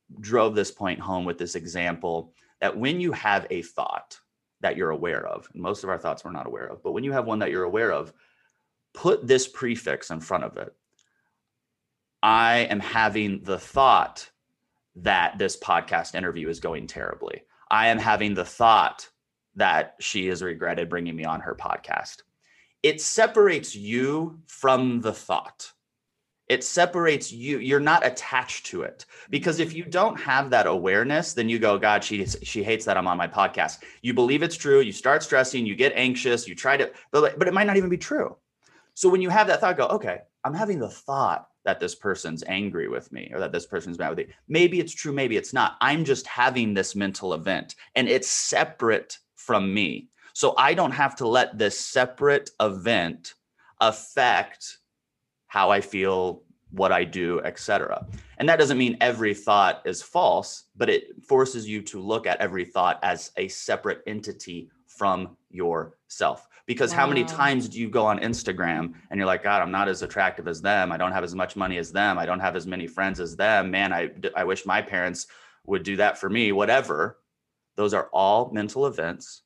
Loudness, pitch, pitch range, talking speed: -24 LUFS, 120 Hz, 100-150 Hz, 195 wpm